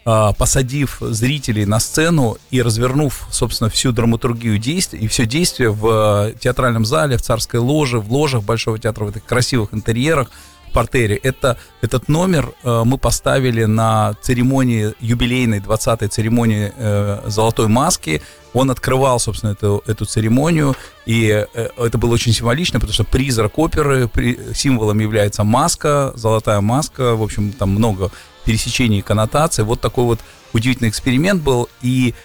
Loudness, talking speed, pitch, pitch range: -16 LUFS, 140 wpm, 120 Hz, 110-130 Hz